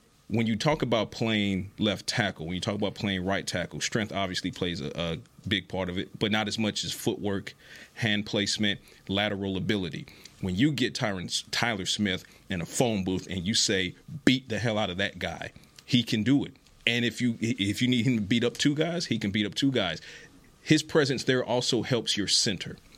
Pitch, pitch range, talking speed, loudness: 105 Hz, 95-120 Hz, 215 wpm, -28 LUFS